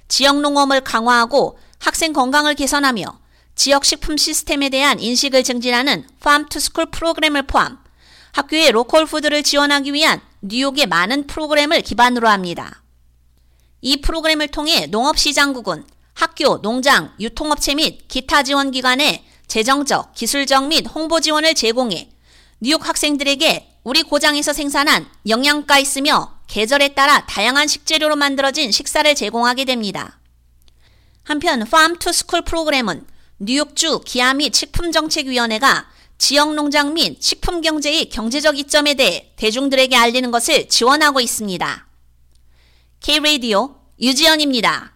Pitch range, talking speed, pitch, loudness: 245-300 Hz, 335 characters per minute, 280 Hz, -15 LUFS